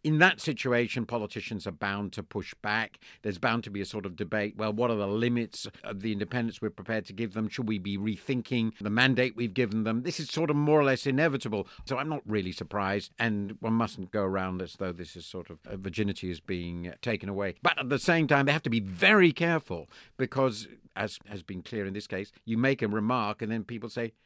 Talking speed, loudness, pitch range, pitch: 235 wpm, -29 LUFS, 100-125 Hz, 110 Hz